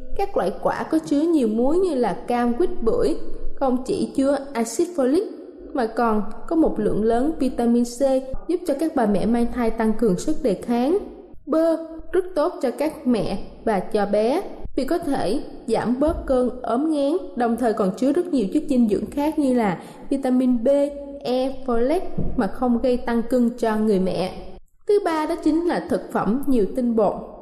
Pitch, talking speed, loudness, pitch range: 260 Hz, 195 wpm, -22 LUFS, 230-315 Hz